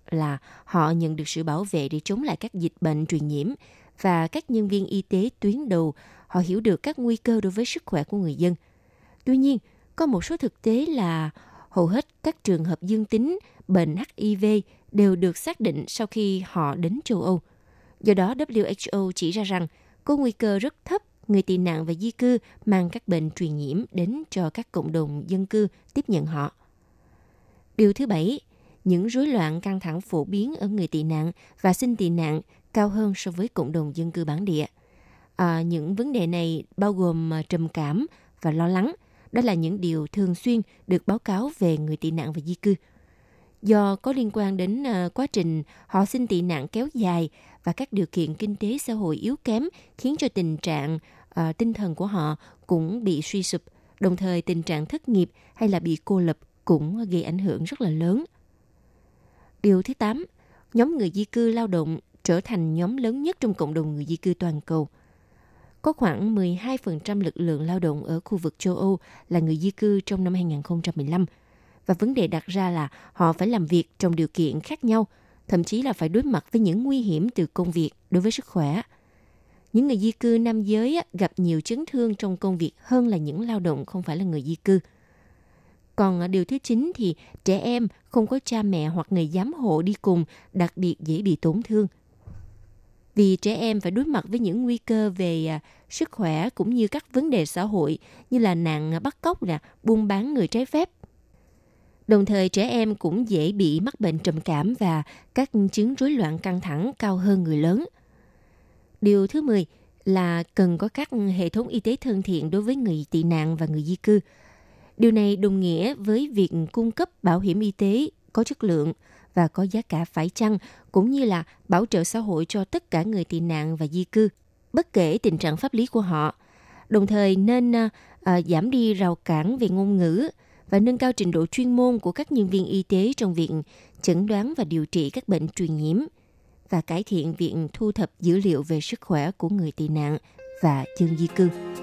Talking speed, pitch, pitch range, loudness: 210 wpm, 190 Hz, 165-225 Hz, -24 LUFS